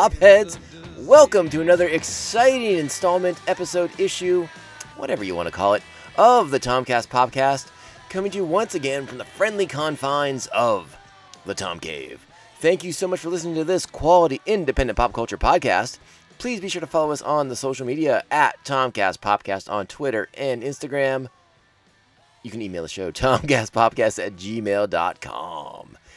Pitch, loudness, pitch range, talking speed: 140 Hz, -21 LUFS, 120-180 Hz, 155 wpm